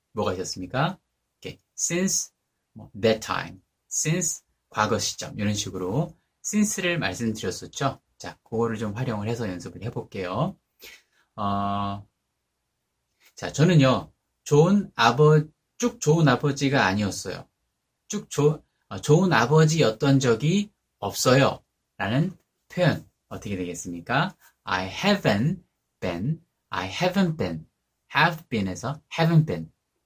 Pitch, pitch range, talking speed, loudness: 130 Hz, 100-165 Hz, 315 characters per minute, -24 LUFS